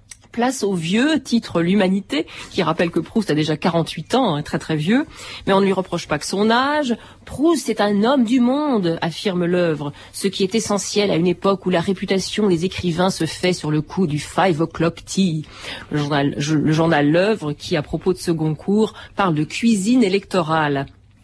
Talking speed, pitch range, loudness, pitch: 200 wpm, 160-210 Hz, -19 LUFS, 185 Hz